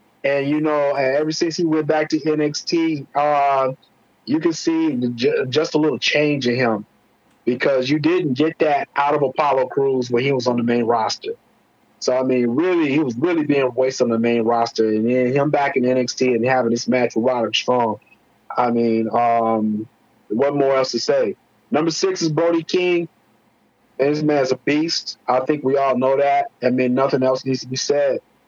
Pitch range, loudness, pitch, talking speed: 125-155 Hz, -19 LUFS, 140 Hz, 200 wpm